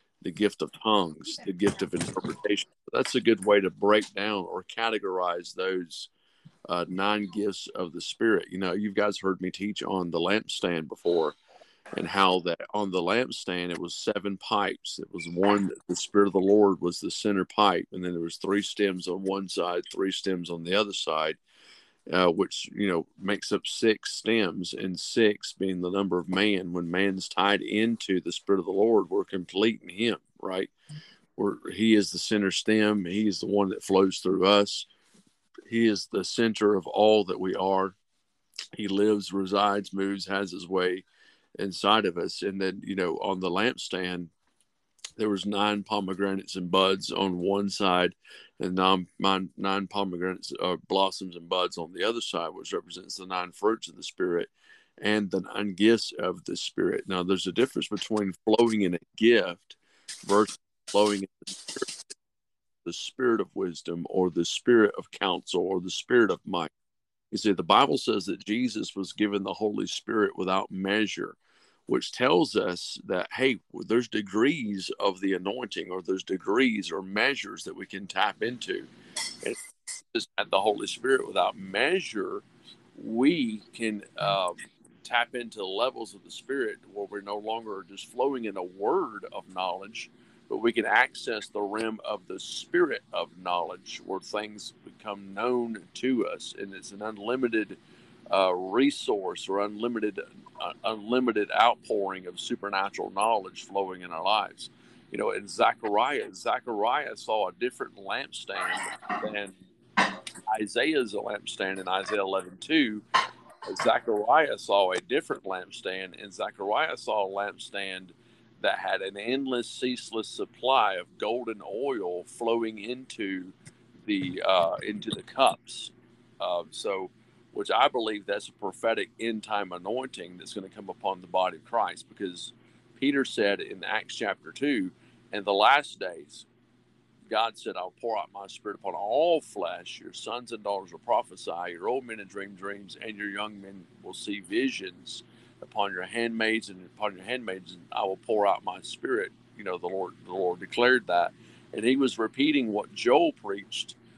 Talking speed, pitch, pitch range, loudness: 170 wpm, 100 Hz, 95-110 Hz, -28 LUFS